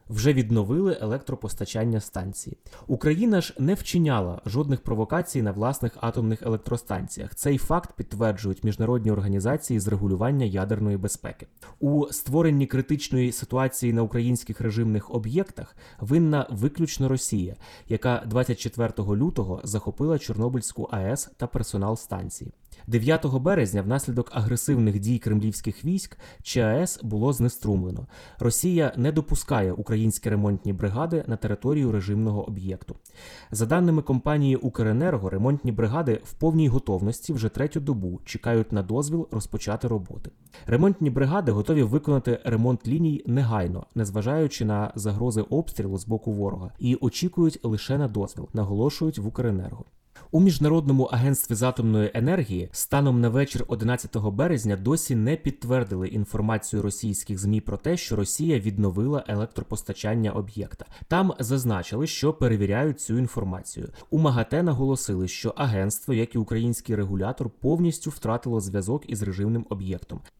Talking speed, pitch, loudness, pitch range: 125 wpm, 115 Hz, -25 LUFS, 105-140 Hz